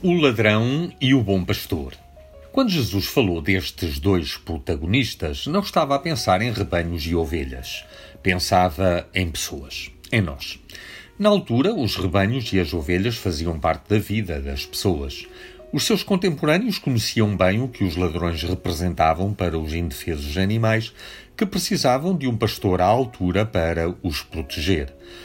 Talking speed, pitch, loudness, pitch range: 145 wpm, 95 Hz, -22 LUFS, 85-120 Hz